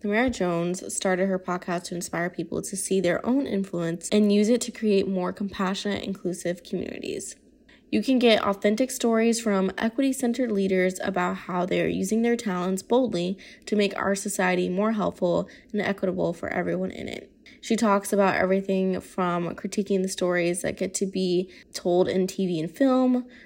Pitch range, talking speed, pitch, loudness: 180-220 Hz, 170 wpm, 195 Hz, -25 LUFS